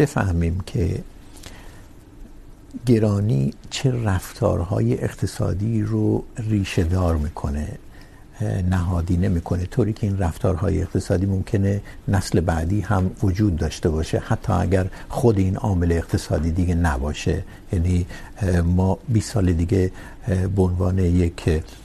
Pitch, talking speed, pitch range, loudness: 95 Hz, 100 wpm, 90-105 Hz, -22 LUFS